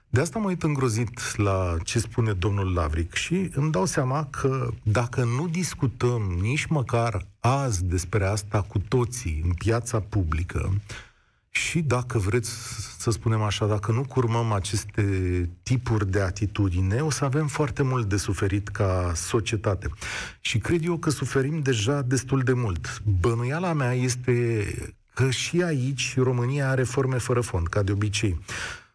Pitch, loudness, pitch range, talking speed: 115 Hz, -26 LUFS, 100-130 Hz, 150 wpm